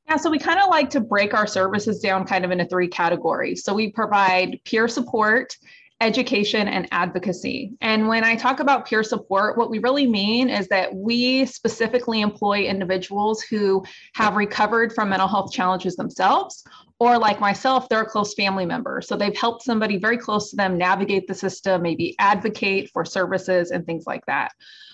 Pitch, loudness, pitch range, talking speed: 210 Hz, -21 LUFS, 190-235 Hz, 185 wpm